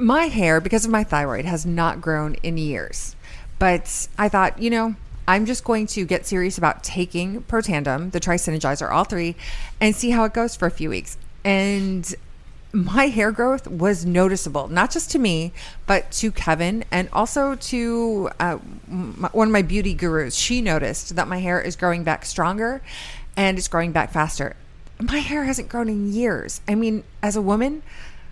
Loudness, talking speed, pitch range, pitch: -22 LUFS, 180 wpm, 170-225 Hz, 190 Hz